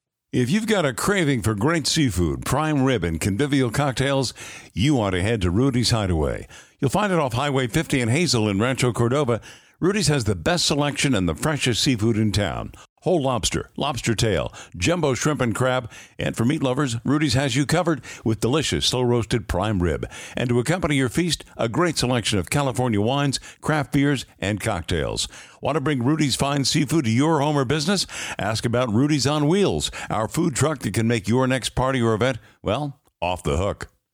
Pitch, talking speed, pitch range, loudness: 130 Hz, 195 wpm, 115-150 Hz, -22 LUFS